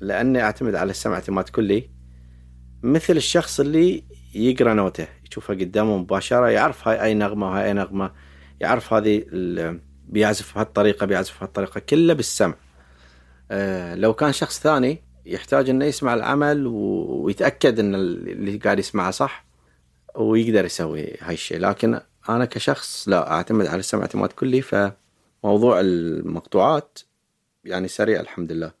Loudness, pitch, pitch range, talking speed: -21 LUFS, 100 Hz, 80-115 Hz, 130 wpm